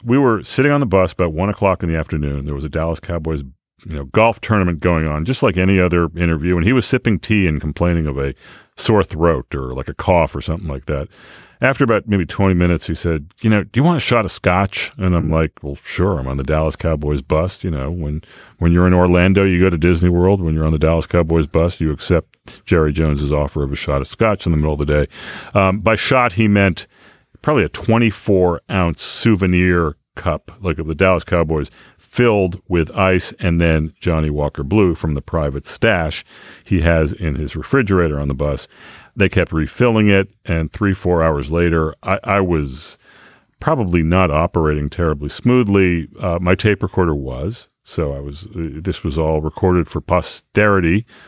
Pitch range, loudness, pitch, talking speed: 80-95 Hz, -17 LUFS, 85 Hz, 205 wpm